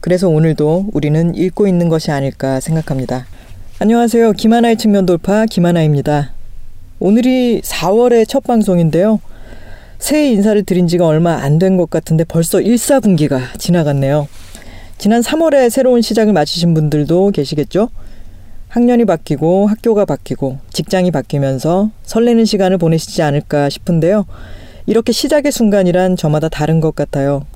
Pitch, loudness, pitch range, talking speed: 175 Hz, -13 LUFS, 150-215 Hz, 340 characters per minute